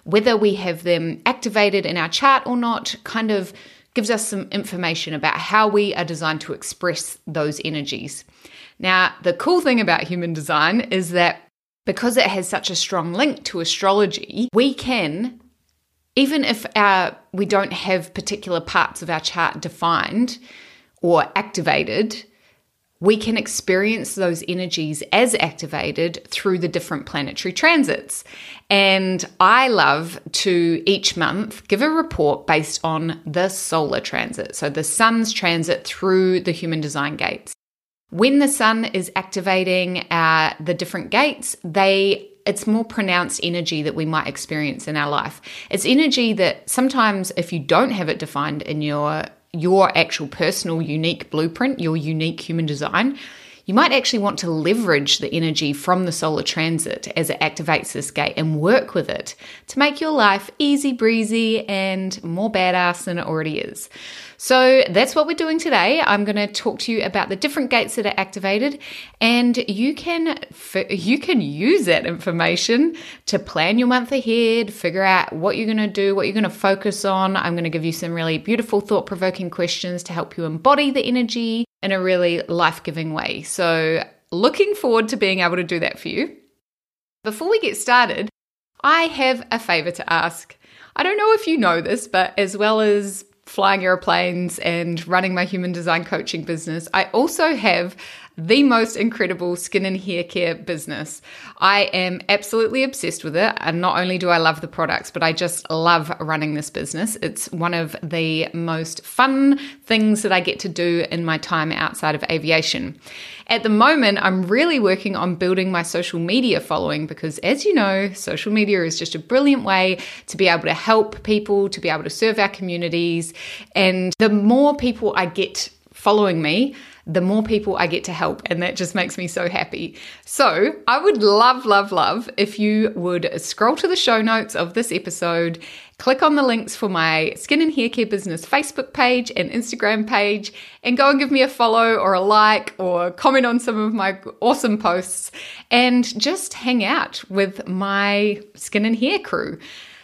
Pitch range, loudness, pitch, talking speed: 170-230 Hz, -19 LUFS, 195 Hz, 180 wpm